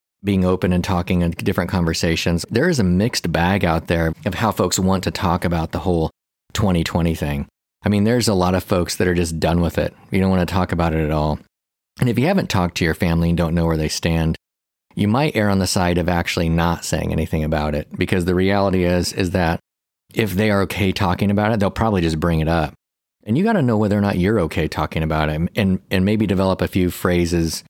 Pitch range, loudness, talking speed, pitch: 80-95 Hz, -19 LUFS, 245 wpm, 90 Hz